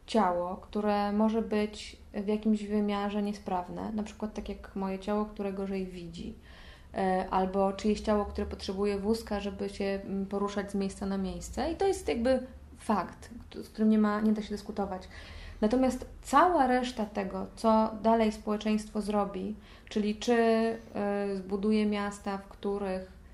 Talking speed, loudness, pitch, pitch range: 145 wpm, -31 LUFS, 205 Hz, 195-215 Hz